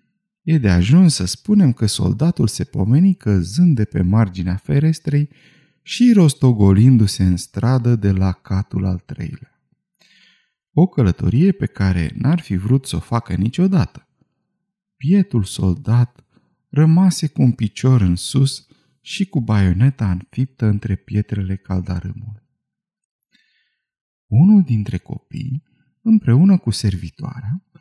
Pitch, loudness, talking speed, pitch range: 130 Hz, -17 LUFS, 120 wpm, 100-165 Hz